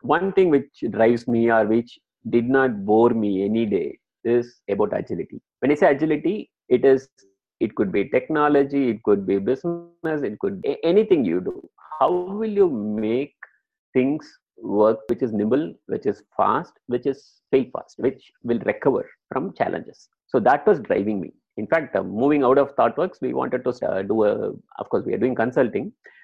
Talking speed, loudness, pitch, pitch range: 185 wpm, -22 LUFS, 130 Hz, 115-180 Hz